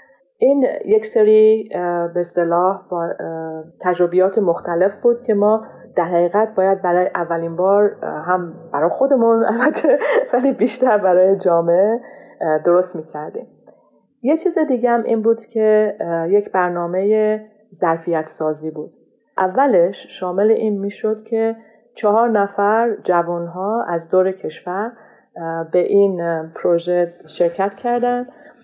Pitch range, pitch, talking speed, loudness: 175-230 Hz, 195 Hz, 115 wpm, -18 LUFS